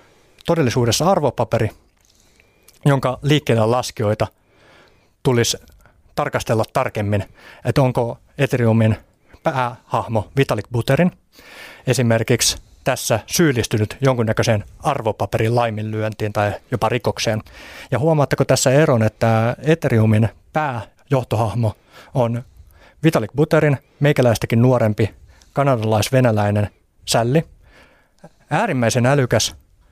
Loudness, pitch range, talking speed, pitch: -19 LUFS, 110-130 Hz, 80 wpm, 115 Hz